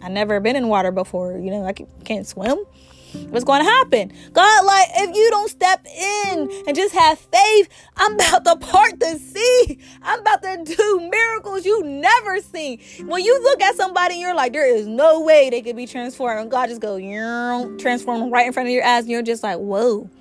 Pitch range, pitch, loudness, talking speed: 240-400 Hz, 325 Hz, -17 LUFS, 215 wpm